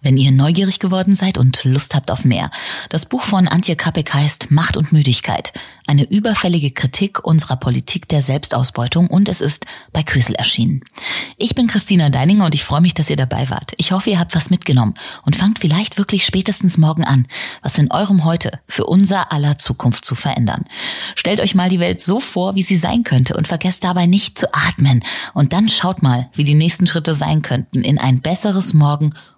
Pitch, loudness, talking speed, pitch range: 160 Hz, -15 LUFS, 200 wpm, 140-185 Hz